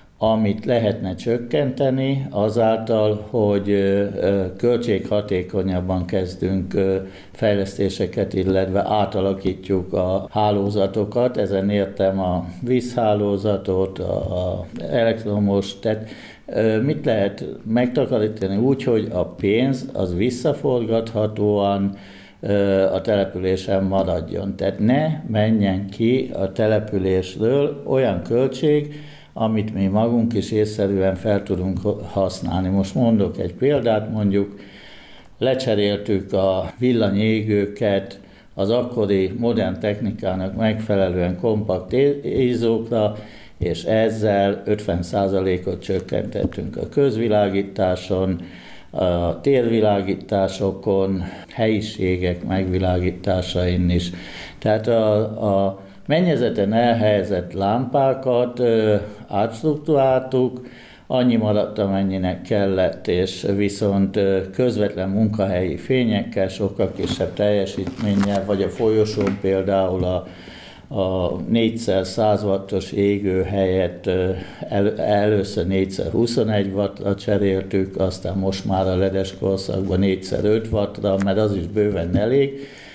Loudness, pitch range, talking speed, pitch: -21 LUFS, 95-110 Hz, 90 wpm, 100 Hz